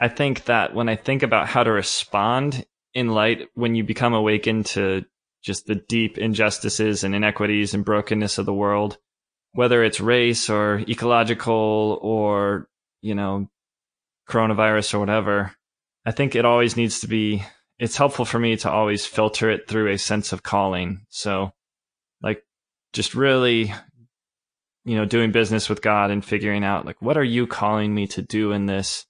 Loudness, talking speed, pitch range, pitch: -21 LUFS, 170 wpm, 105-115 Hz, 110 Hz